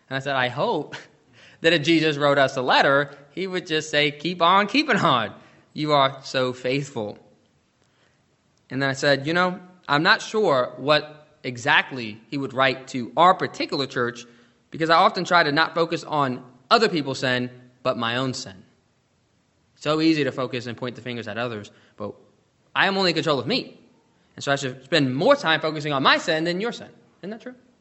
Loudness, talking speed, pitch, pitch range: -22 LUFS, 200 wpm, 140 Hz, 125-165 Hz